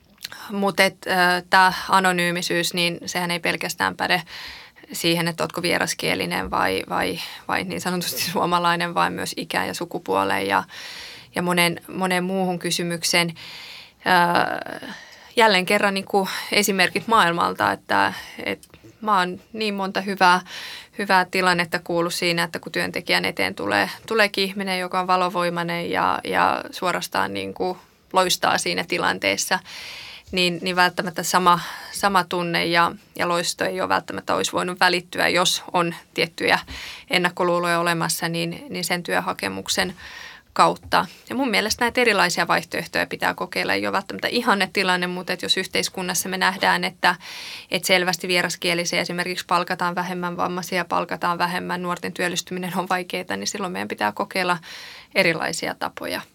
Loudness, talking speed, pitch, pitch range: -21 LUFS, 135 wpm, 180 Hz, 170-185 Hz